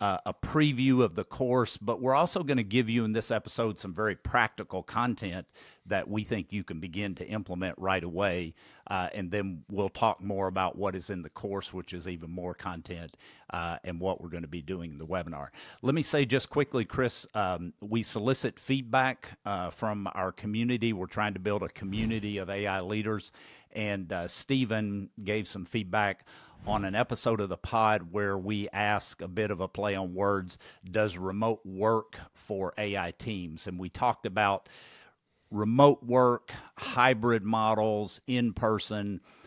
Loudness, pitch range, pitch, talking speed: -31 LUFS, 95-115 Hz, 105 Hz, 180 wpm